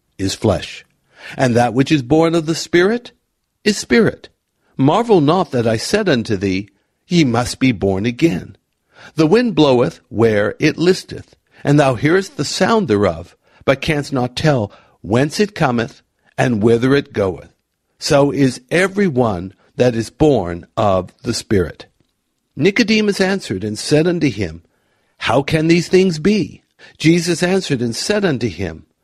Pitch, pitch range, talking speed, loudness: 135 Hz, 110-170 Hz, 155 wpm, -16 LUFS